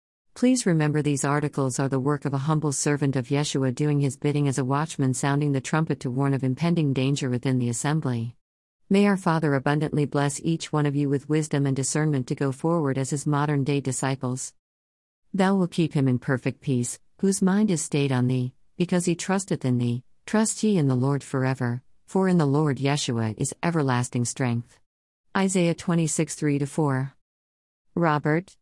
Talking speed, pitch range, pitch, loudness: 185 wpm, 130-155 Hz, 140 Hz, -25 LUFS